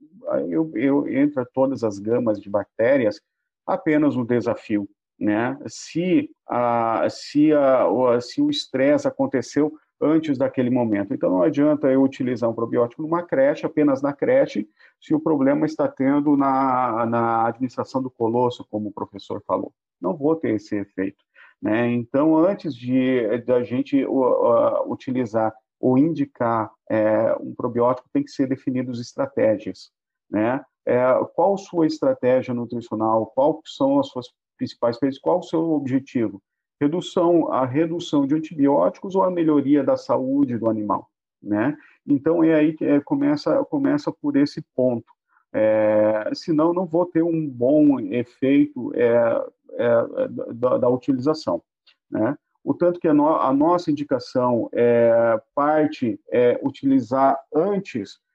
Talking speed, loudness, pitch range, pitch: 145 wpm, -21 LUFS, 120-170 Hz, 140 Hz